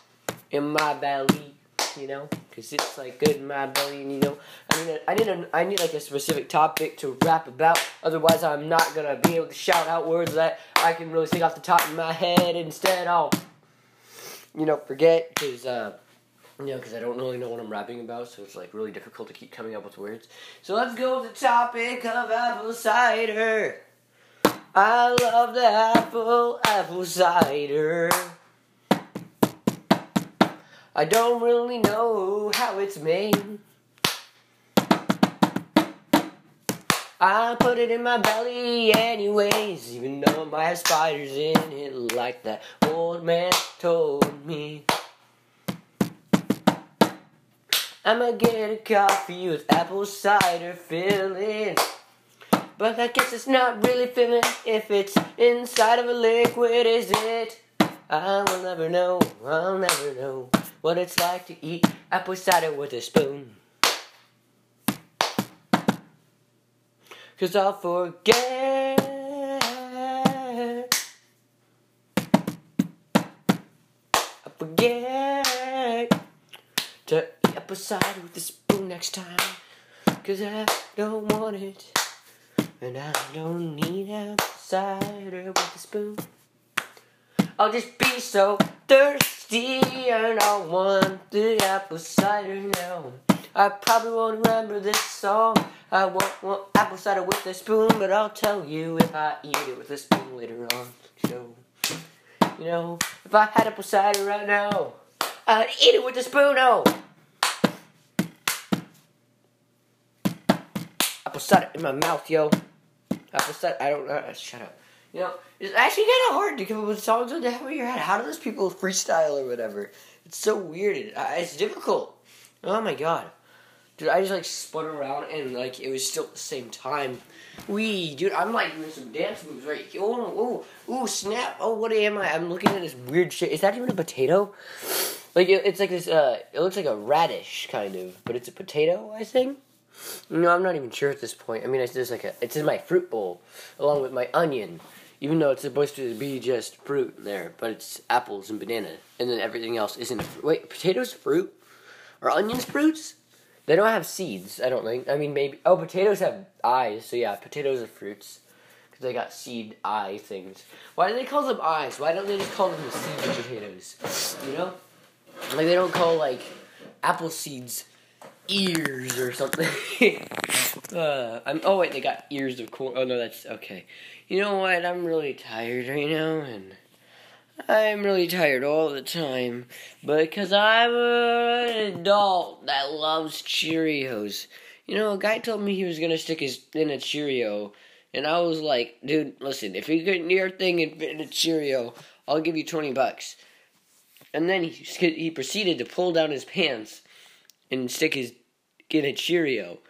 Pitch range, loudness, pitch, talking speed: 155-225 Hz, -24 LUFS, 185 Hz, 165 wpm